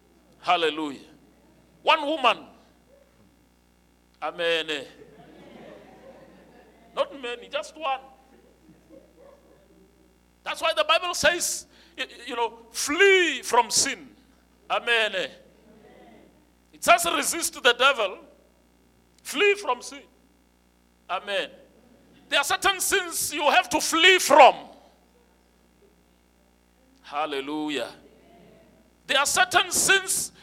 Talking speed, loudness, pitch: 85 wpm, -23 LUFS, 245 Hz